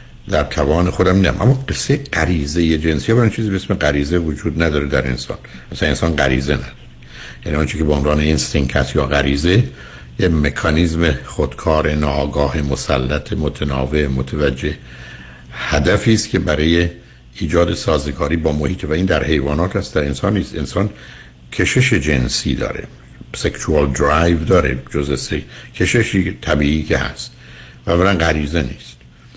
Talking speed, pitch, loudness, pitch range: 140 wpm, 75 Hz, -17 LUFS, 70-90 Hz